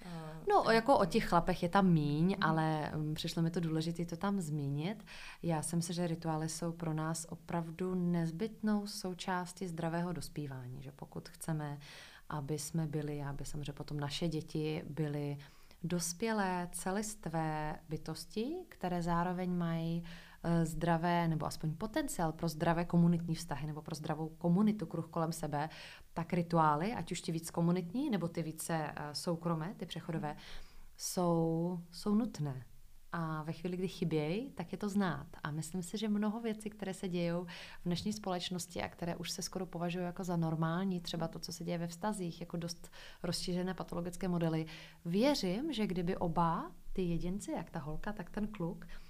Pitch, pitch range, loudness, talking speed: 170 Hz, 160-185 Hz, -37 LUFS, 160 wpm